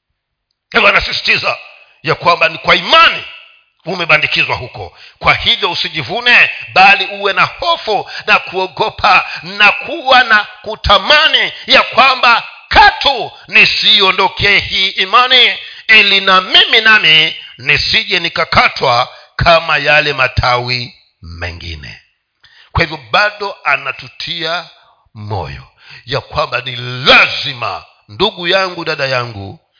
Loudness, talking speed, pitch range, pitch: -9 LUFS, 100 wpm, 125-210 Hz, 170 Hz